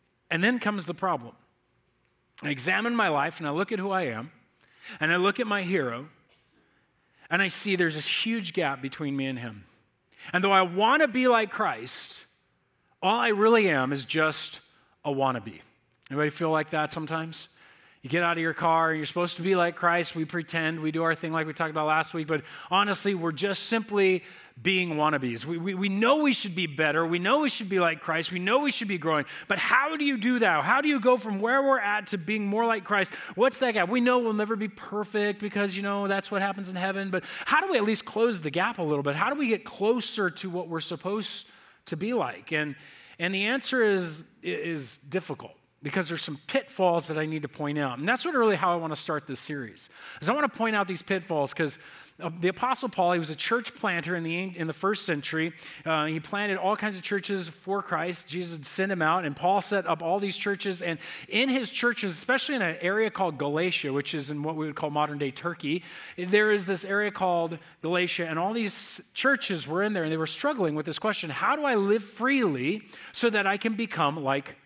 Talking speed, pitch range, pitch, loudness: 230 wpm, 160-210 Hz, 185 Hz, -27 LUFS